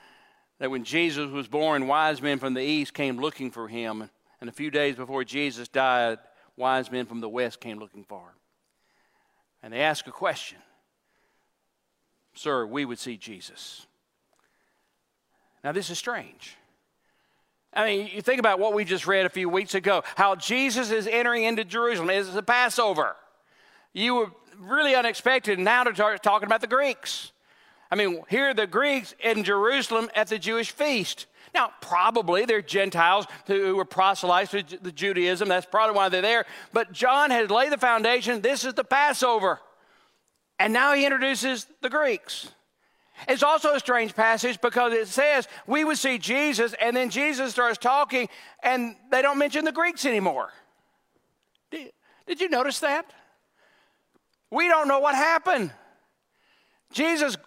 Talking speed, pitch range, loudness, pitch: 160 wpm, 180-265 Hz, -24 LUFS, 225 Hz